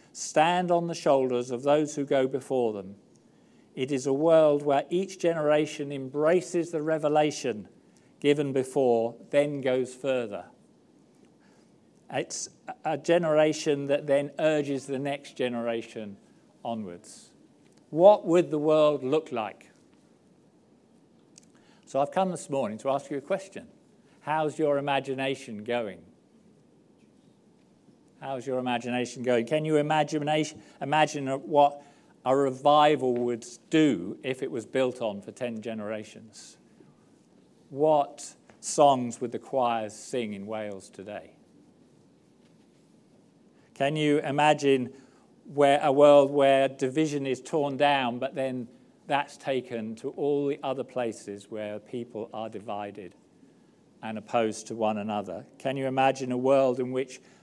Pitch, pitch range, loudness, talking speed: 135 Hz, 120-150 Hz, -27 LUFS, 125 wpm